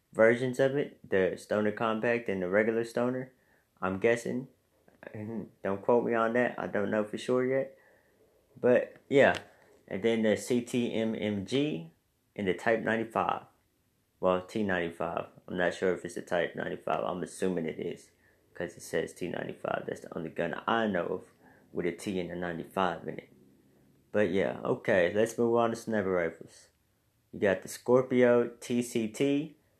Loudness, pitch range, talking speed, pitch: -30 LUFS, 95-120 Hz, 160 wpm, 110 Hz